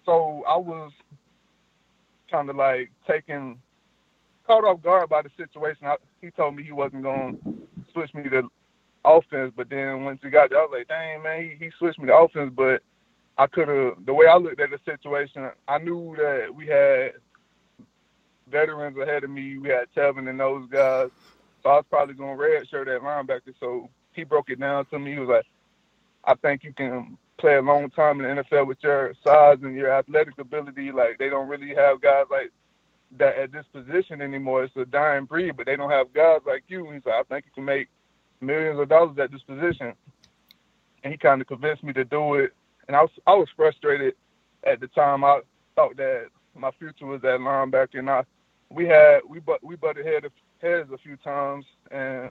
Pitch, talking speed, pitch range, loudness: 145 Hz, 210 wpm, 135-165 Hz, -22 LUFS